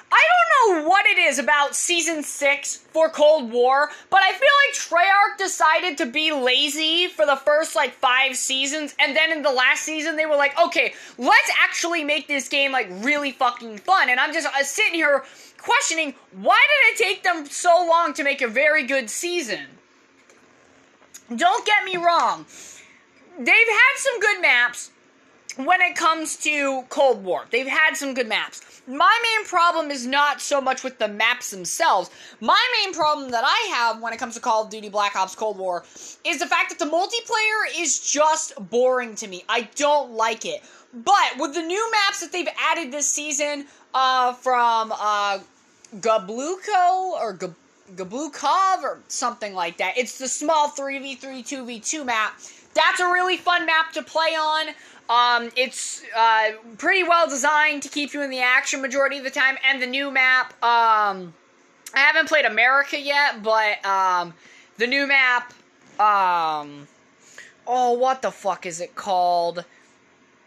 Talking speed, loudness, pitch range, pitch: 170 wpm, -20 LUFS, 245-330 Hz, 285 Hz